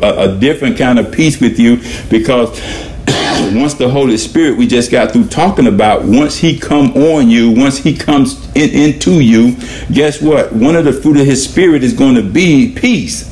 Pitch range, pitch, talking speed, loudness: 125-165 Hz, 145 Hz, 185 wpm, -10 LUFS